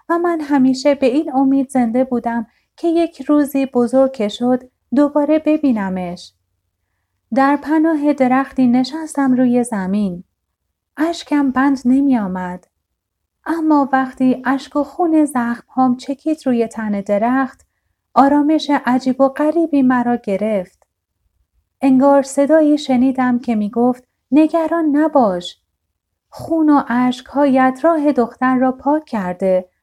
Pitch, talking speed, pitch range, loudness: 260 Hz, 120 wpm, 235-290 Hz, -16 LUFS